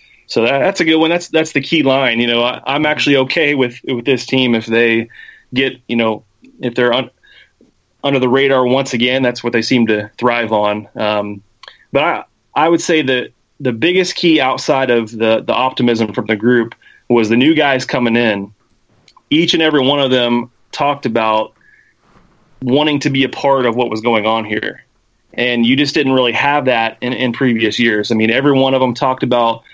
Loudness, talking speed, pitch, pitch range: -14 LUFS, 210 wpm, 125 Hz, 115-135 Hz